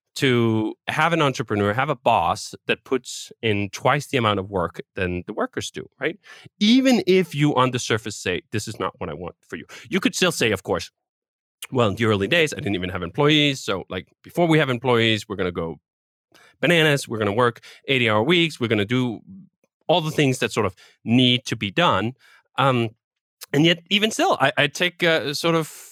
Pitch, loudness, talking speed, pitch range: 130 Hz, -21 LUFS, 220 wpm, 115-160 Hz